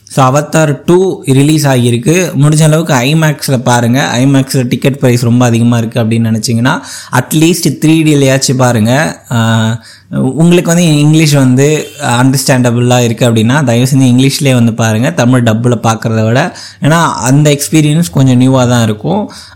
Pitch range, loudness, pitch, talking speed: 120-150 Hz, -9 LUFS, 130 Hz, 140 wpm